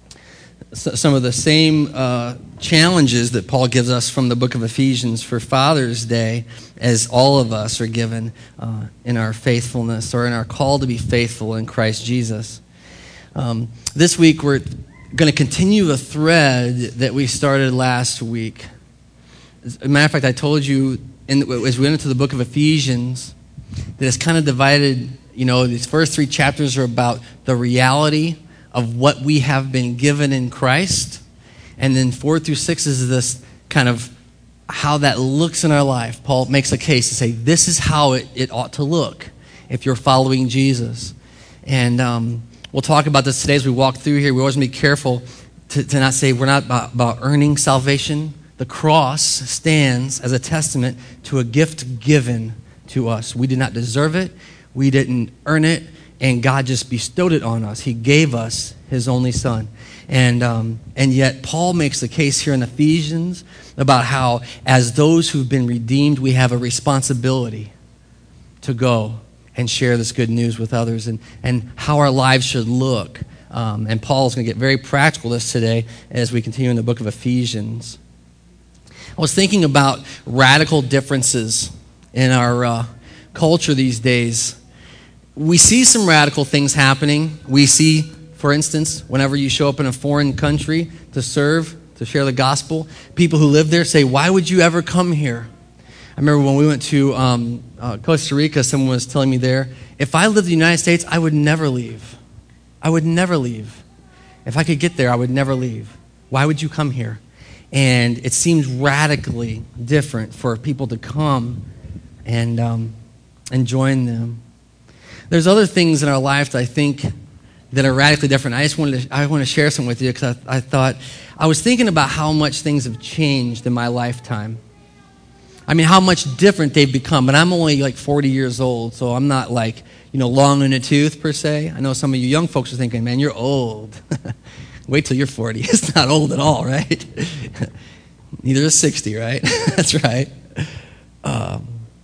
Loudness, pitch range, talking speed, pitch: -16 LUFS, 120-150 Hz, 185 wpm, 130 Hz